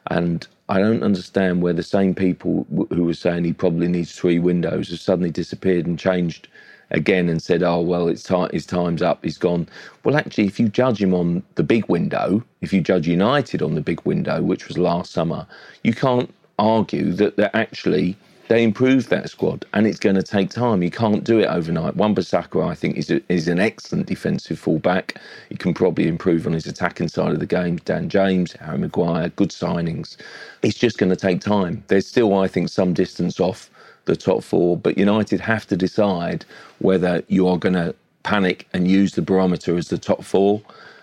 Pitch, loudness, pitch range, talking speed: 95 Hz, -20 LUFS, 85-100 Hz, 205 wpm